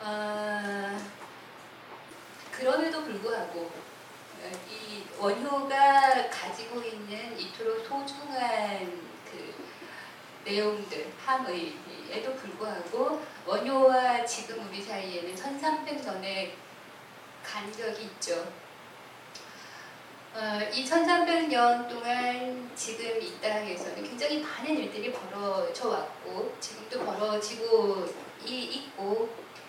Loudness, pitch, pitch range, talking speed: -30 LUFS, 230 Hz, 205-270 Hz, 180 characters per minute